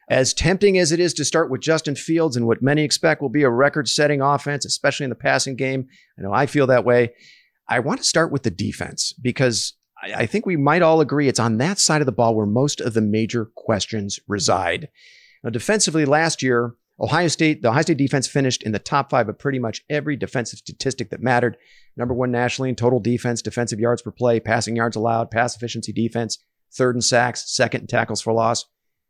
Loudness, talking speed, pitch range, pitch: -20 LUFS, 220 wpm, 115-150 Hz, 125 Hz